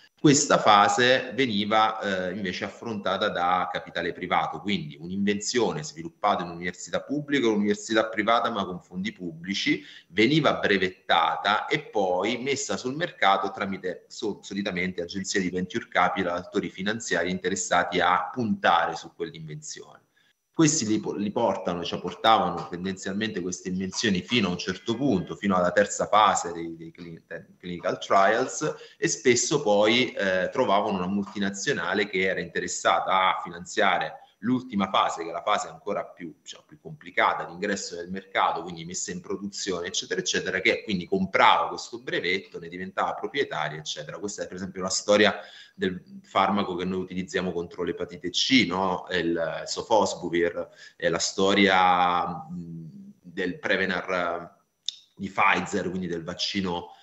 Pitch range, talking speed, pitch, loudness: 90-110 Hz, 140 wpm, 95 Hz, -25 LUFS